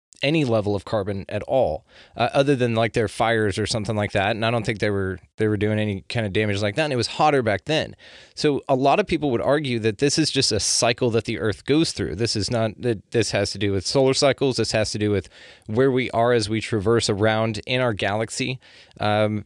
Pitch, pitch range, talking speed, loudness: 110 Hz, 105-125 Hz, 255 wpm, -22 LUFS